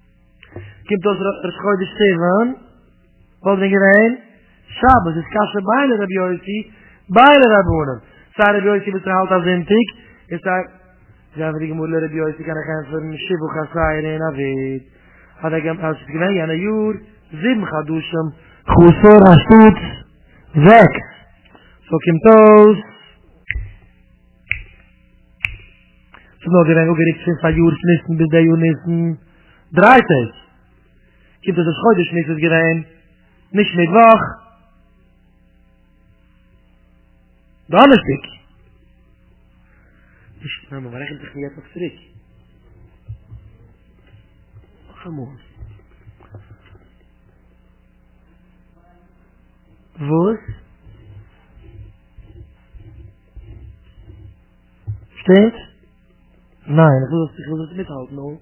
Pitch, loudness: 160 Hz, -14 LUFS